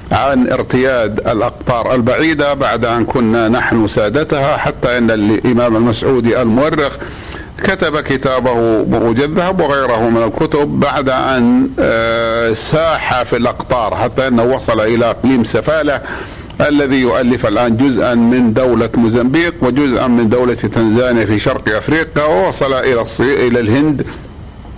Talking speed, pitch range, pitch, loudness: 120 wpm, 115-140 Hz, 125 Hz, -13 LUFS